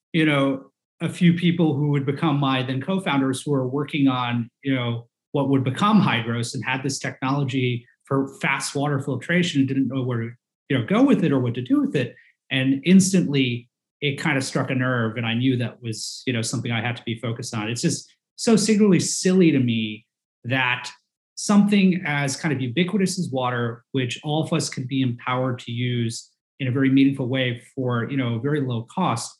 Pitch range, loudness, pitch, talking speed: 125-155 Hz, -22 LUFS, 135 Hz, 210 wpm